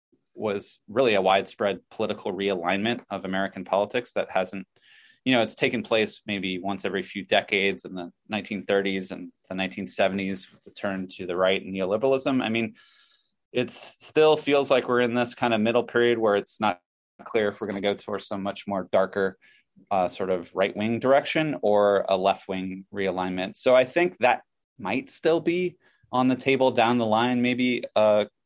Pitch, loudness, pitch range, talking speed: 105 Hz, -25 LUFS, 95-125 Hz, 185 wpm